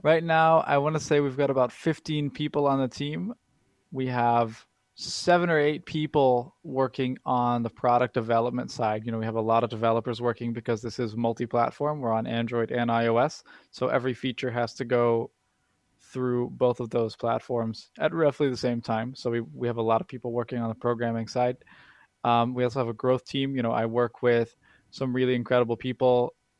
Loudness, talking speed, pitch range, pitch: -27 LUFS, 200 wpm, 115-135 Hz, 125 Hz